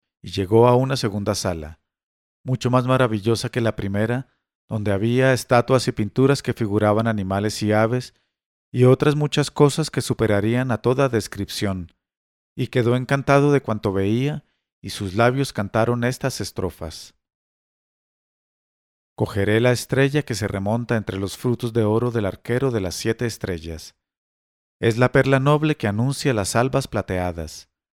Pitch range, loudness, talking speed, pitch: 100-130 Hz, -21 LUFS, 150 wpm, 115 Hz